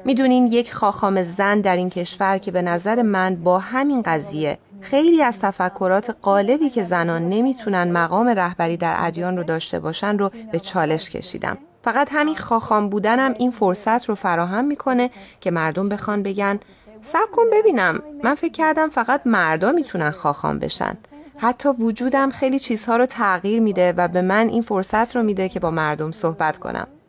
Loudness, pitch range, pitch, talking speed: -20 LUFS, 180-245 Hz, 205 Hz, 165 wpm